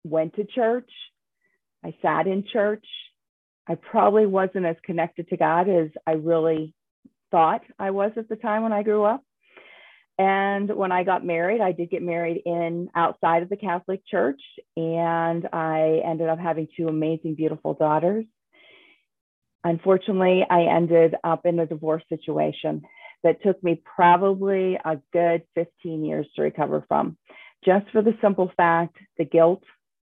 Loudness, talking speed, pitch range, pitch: -23 LUFS, 155 wpm, 165-195 Hz, 175 Hz